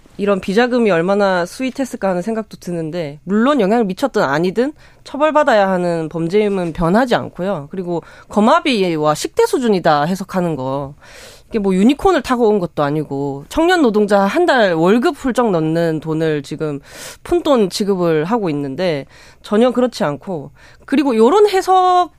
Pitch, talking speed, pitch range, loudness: 200 Hz, 335 characters per minute, 165-250 Hz, -16 LUFS